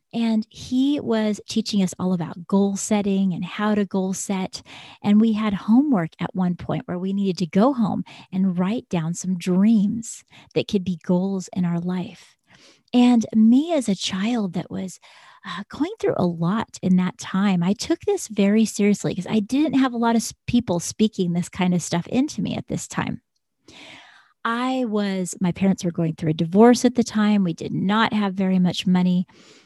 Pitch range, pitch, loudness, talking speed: 180-225 Hz, 200 Hz, -22 LUFS, 190 wpm